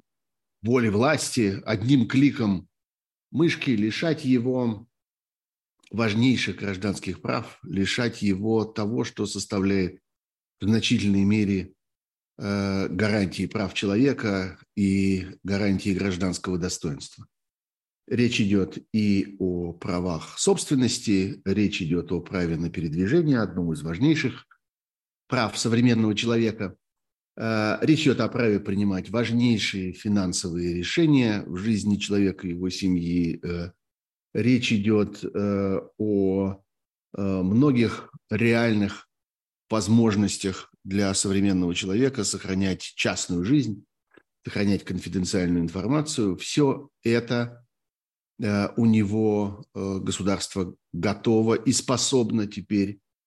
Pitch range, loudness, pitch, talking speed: 95-115 Hz, -25 LUFS, 100 Hz, 90 wpm